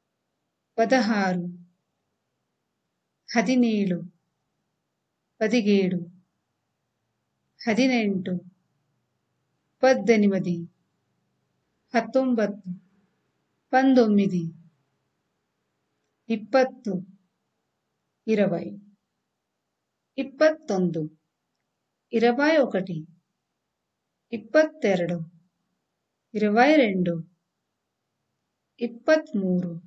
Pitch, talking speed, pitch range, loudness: 195 Hz, 30 wpm, 175-235 Hz, -24 LUFS